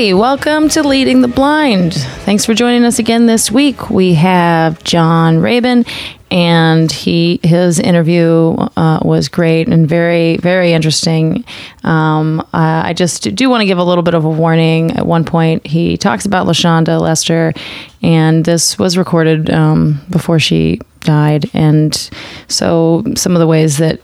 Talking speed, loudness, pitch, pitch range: 160 wpm, -11 LUFS, 170 Hz, 160-195 Hz